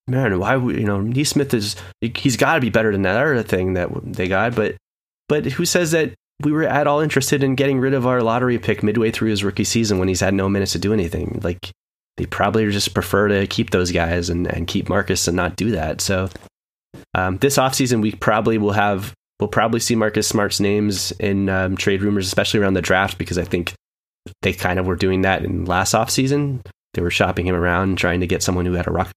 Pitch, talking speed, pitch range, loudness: 100 Hz, 230 wpm, 95-115 Hz, -19 LUFS